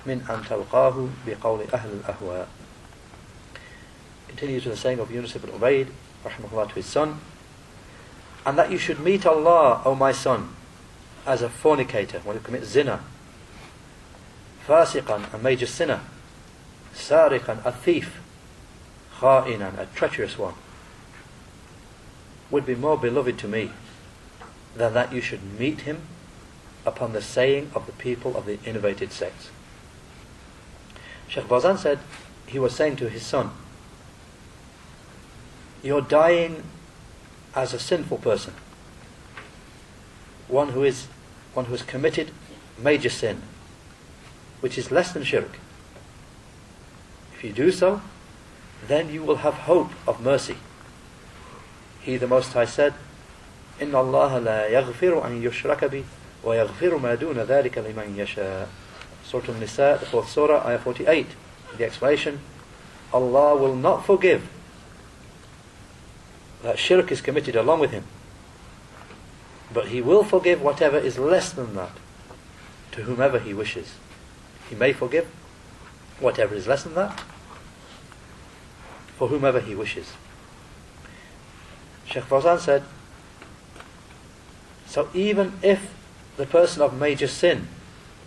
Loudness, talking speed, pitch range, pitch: -23 LUFS, 115 wpm, 115-150 Hz, 130 Hz